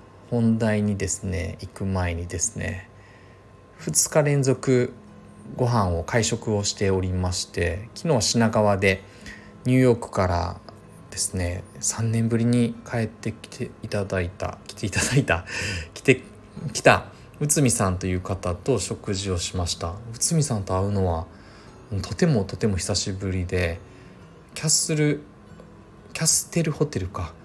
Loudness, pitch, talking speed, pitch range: -24 LUFS, 105 Hz, 275 characters per minute, 95-115 Hz